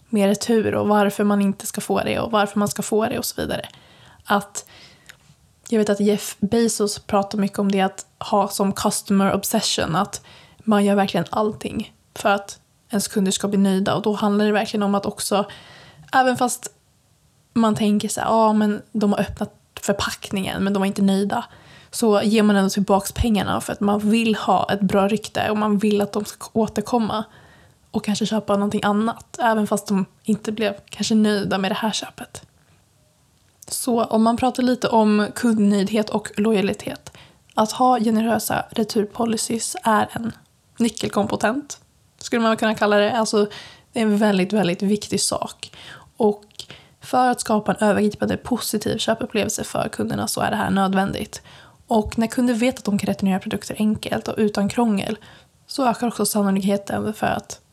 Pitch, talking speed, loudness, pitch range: 210 Hz, 175 wpm, -21 LUFS, 200-225 Hz